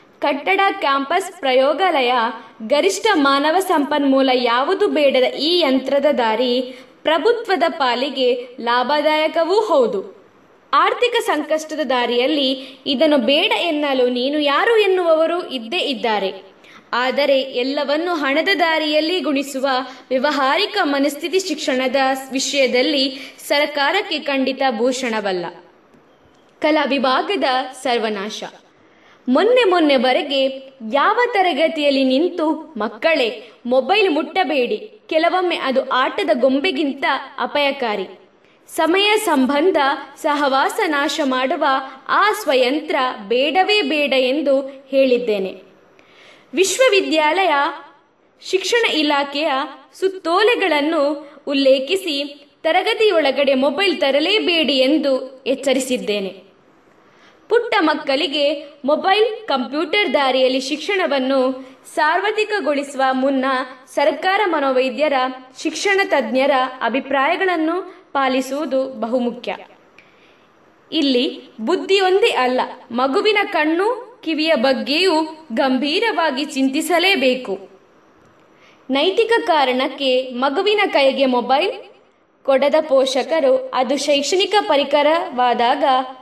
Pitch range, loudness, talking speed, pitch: 265-335 Hz, -17 LUFS, 75 wpm, 285 Hz